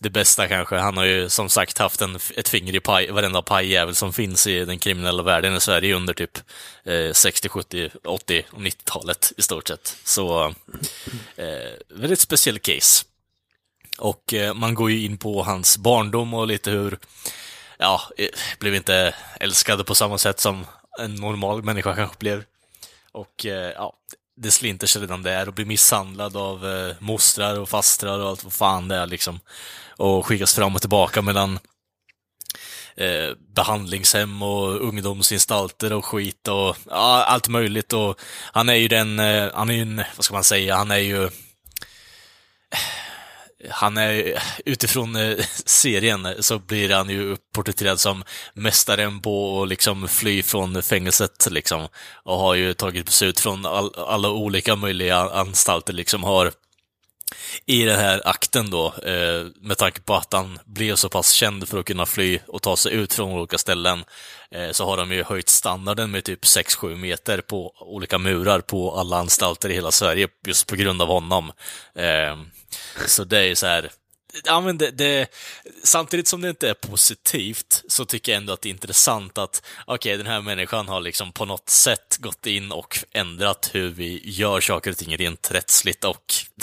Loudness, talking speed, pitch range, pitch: -19 LUFS, 175 wpm, 95-105 Hz, 100 Hz